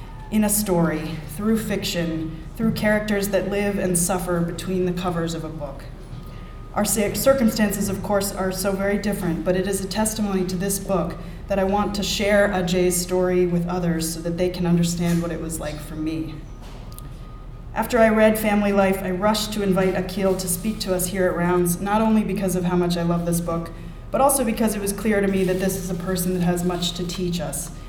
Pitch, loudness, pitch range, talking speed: 185 Hz, -22 LUFS, 170-200 Hz, 215 wpm